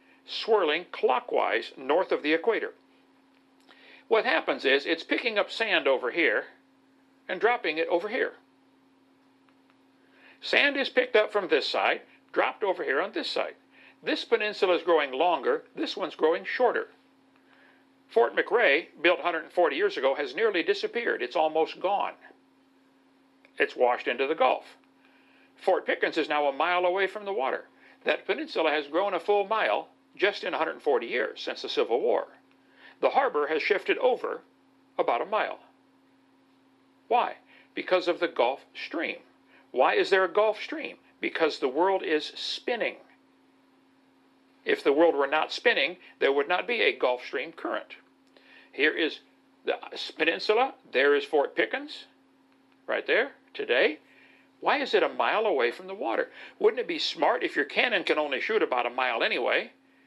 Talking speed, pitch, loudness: 155 wpm, 395 Hz, -27 LUFS